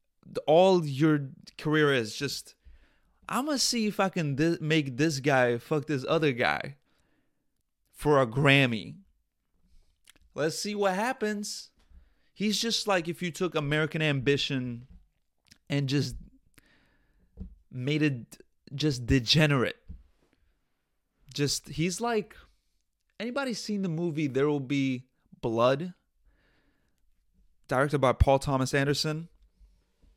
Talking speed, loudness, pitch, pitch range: 110 wpm, -28 LUFS, 145 Hz, 125-170 Hz